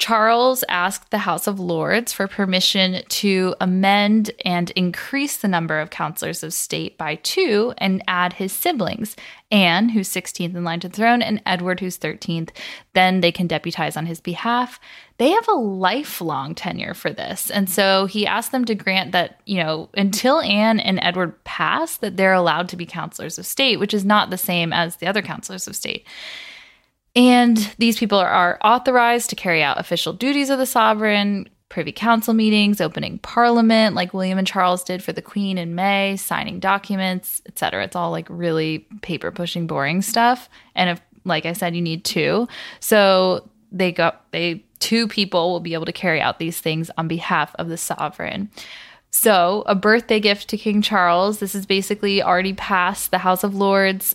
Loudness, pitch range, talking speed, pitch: -19 LUFS, 175-215 Hz, 185 wpm, 190 Hz